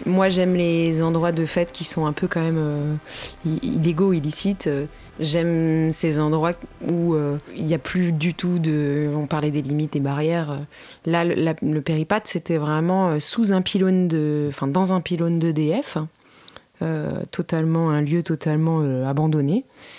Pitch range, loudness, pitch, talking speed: 155-175 Hz, -22 LUFS, 165 Hz, 170 wpm